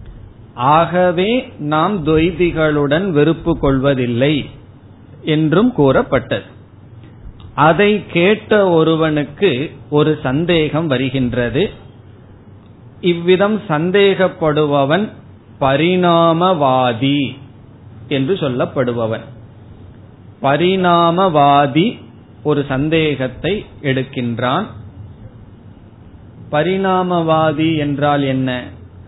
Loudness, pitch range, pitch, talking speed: -15 LUFS, 115-160 Hz, 140 Hz, 50 wpm